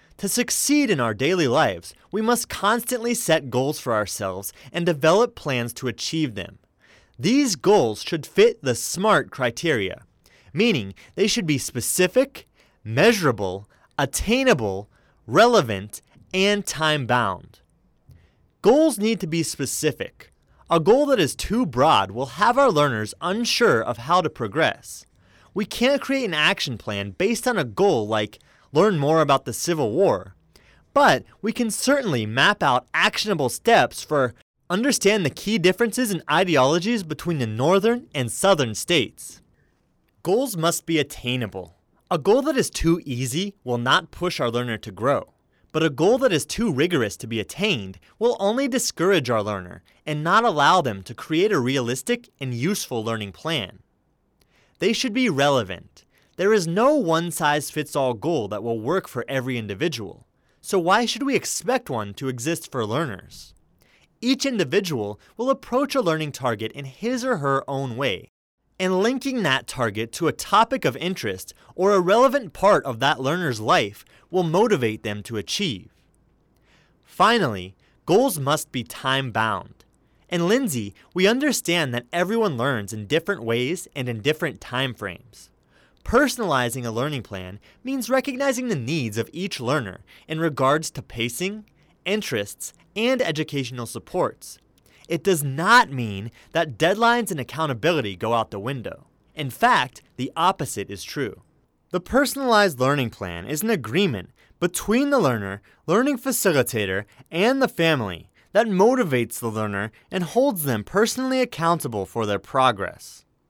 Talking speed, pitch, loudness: 150 wpm, 155 Hz, -22 LUFS